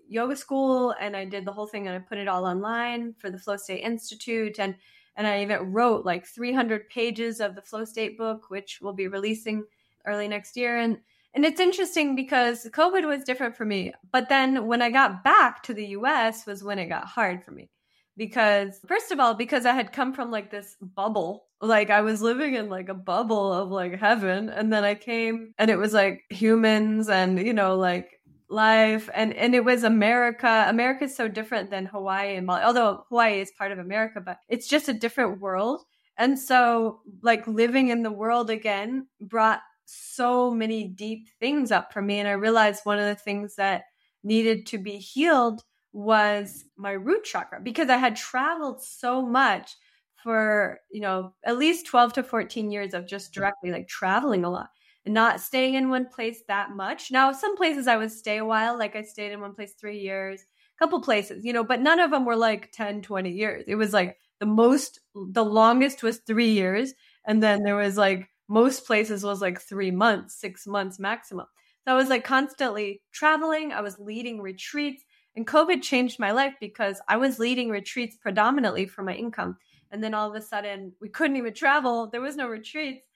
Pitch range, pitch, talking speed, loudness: 205-245 Hz, 220 Hz, 205 wpm, -25 LUFS